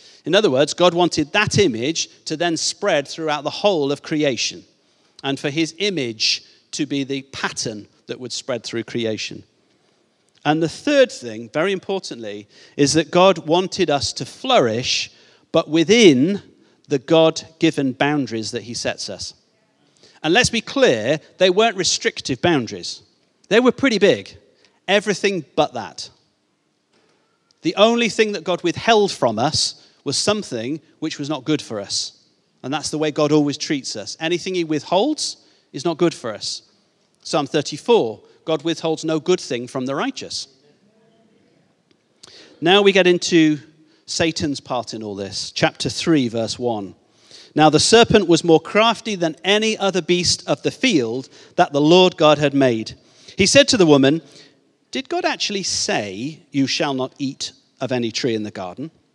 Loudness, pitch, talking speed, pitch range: -19 LUFS, 160 Hz, 160 wpm, 140-185 Hz